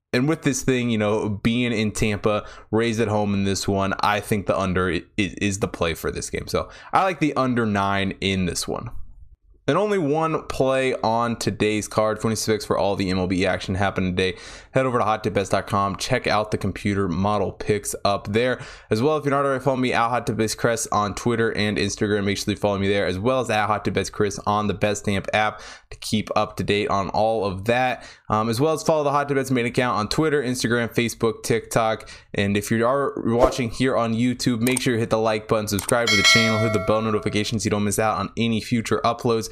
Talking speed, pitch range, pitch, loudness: 225 wpm, 100-120 Hz, 110 Hz, -22 LUFS